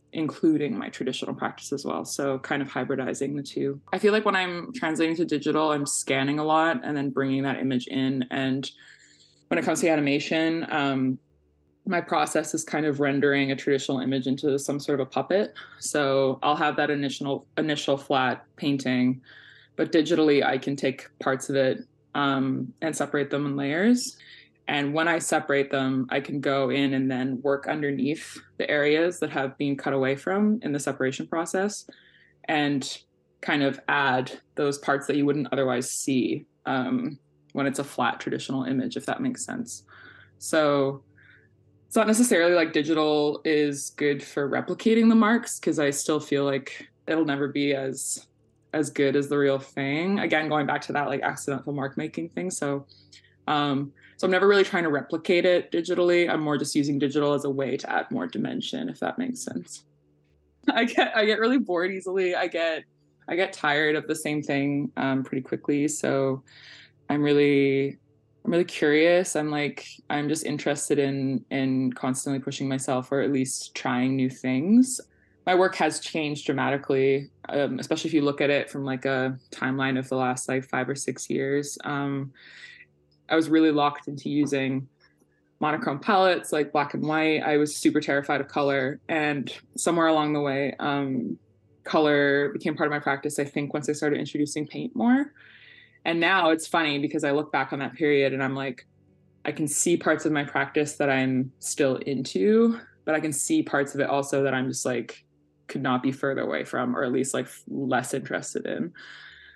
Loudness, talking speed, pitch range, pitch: -25 LUFS, 185 wpm, 135-155 Hz, 145 Hz